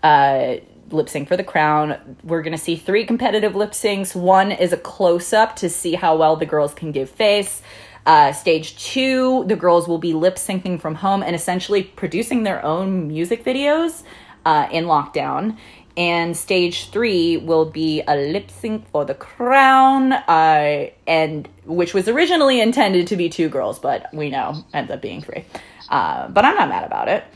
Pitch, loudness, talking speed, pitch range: 180 Hz, -18 LUFS, 180 wpm, 160-215 Hz